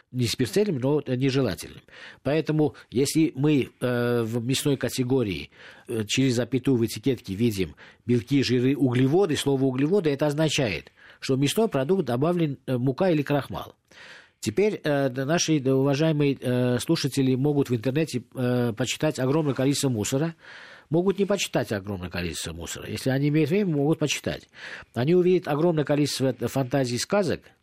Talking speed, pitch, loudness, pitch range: 145 wpm, 135 Hz, -25 LUFS, 125-155 Hz